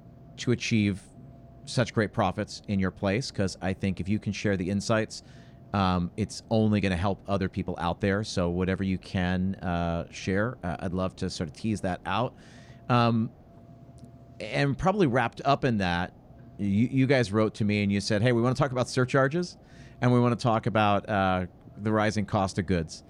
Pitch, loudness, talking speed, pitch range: 105 Hz, -27 LUFS, 200 wpm, 95-125 Hz